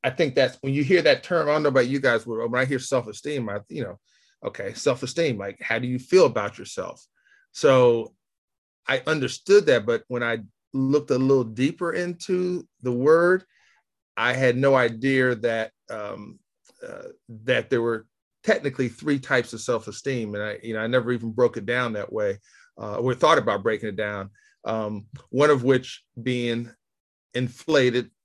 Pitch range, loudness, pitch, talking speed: 115-165 Hz, -23 LUFS, 130 Hz, 180 wpm